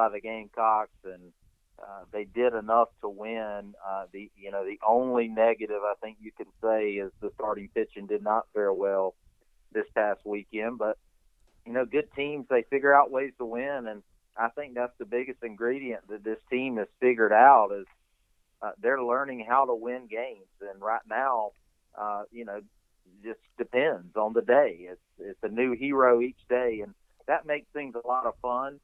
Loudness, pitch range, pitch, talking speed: -28 LUFS, 105-125 Hz, 110 Hz, 190 wpm